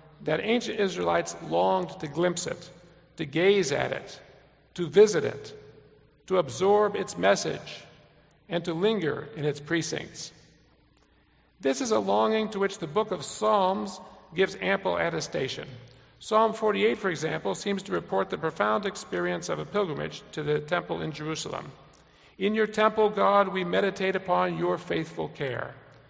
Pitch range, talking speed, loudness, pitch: 155-200 Hz, 150 wpm, -27 LUFS, 180 Hz